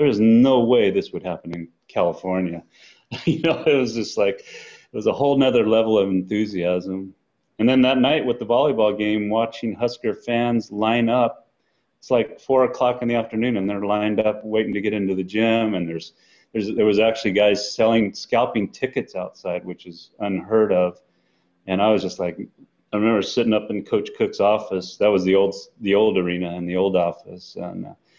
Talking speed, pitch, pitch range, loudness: 200 wpm, 105 Hz, 95-115 Hz, -21 LUFS